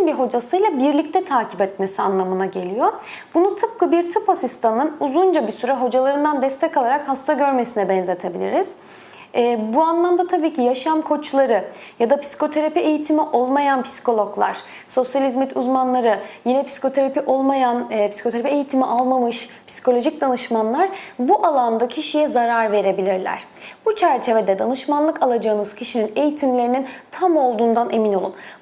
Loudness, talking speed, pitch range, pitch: -19 LUFS, 125 wpm, 235-300 Hz, 265 Hz